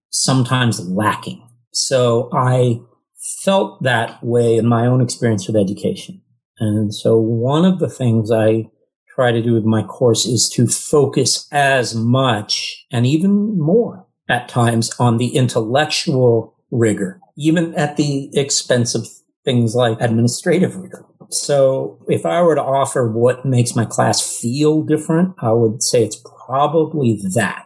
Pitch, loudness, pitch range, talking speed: 125 Hz, -16 LUFS, 115-150 Hz, 145 wpm